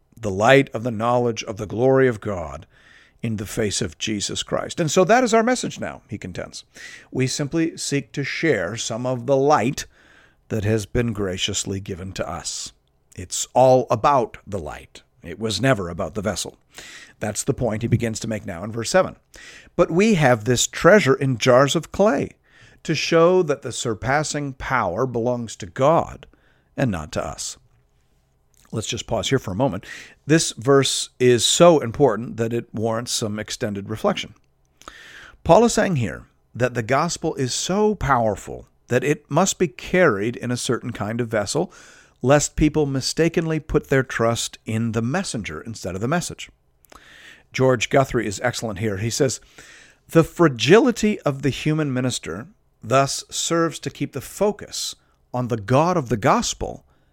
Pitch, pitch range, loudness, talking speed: 125 Hz, 110-150 Hz, -21 LUFS, 170 wpm